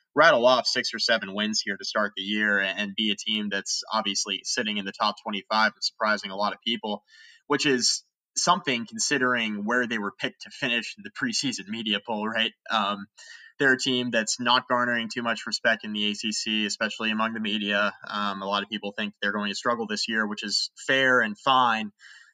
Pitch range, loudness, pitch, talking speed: 105-115 Hz, -25 LUFS, 110 Hz, 205 wpm